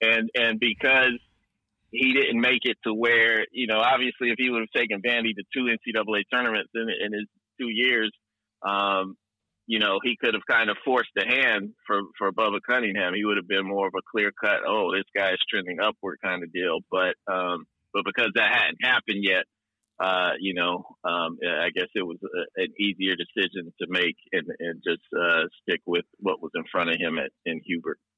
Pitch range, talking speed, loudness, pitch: 95-120 Hz, 205 wpm, -25 LUFS, 110 Hz